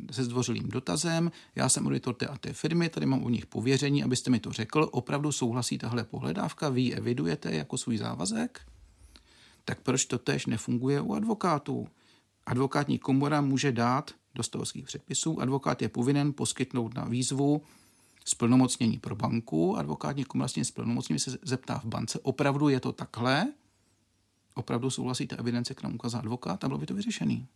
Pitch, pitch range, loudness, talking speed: 130 Hz, 120-140 Hz, -30 LUFS, 165 wpm